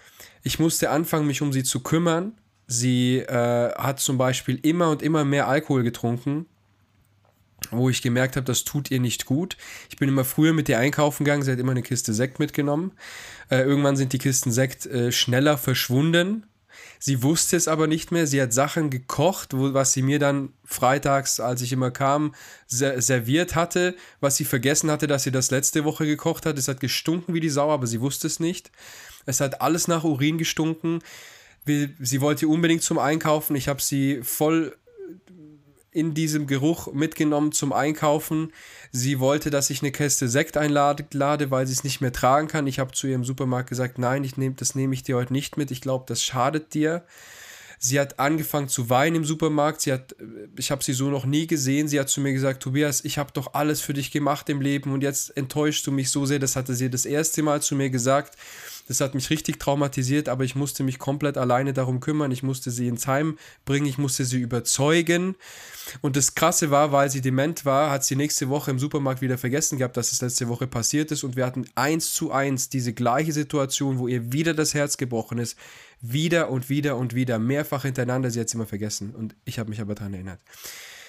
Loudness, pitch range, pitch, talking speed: -23 LUFS, 130-150 Hz, 140 Hz, 210 wpm